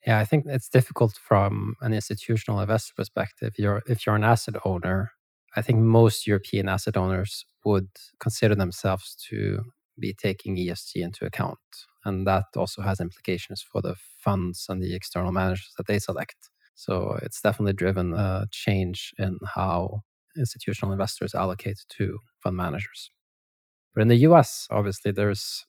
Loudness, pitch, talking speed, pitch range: -26 LUFS, 100 Hz, 155 wpm, 95-110 Hz